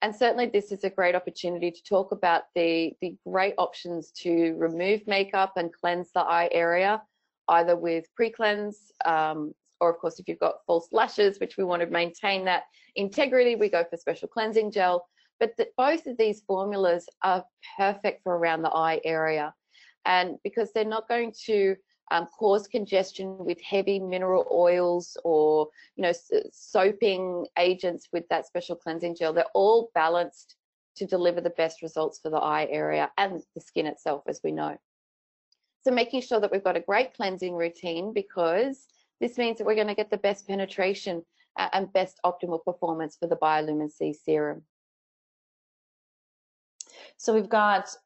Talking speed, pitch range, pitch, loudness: 170 wpm, 170-205 Hz, 180 Hz, -27 LUFS